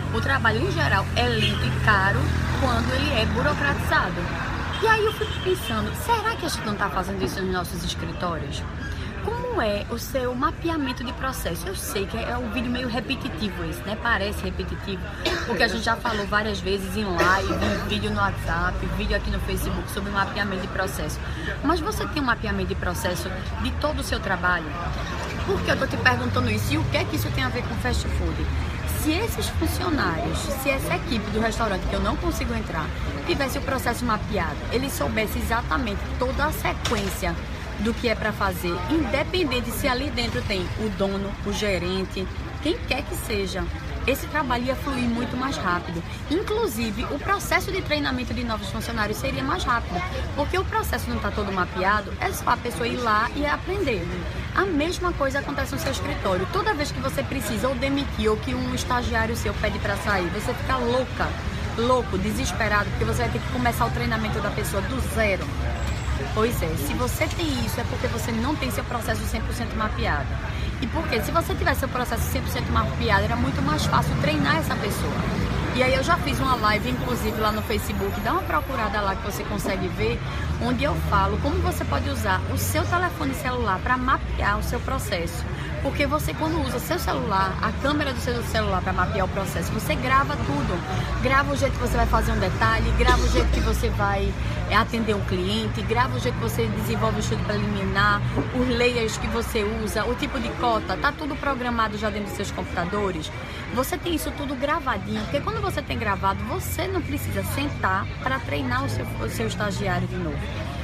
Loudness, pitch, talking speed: -25 LUFS, 120 Hz, 200 wpm